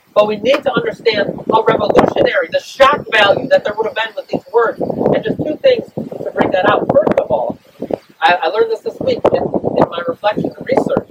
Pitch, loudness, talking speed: 280 Hz, -15 LUFS, 210 wpm